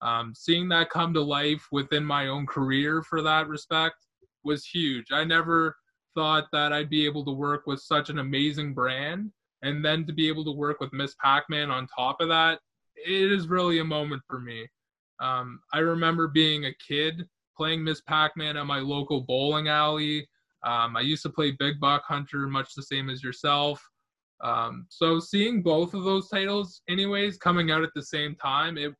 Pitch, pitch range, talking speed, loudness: 150 Hz, 140-165 Hz, 195 wpm, -26 LUFS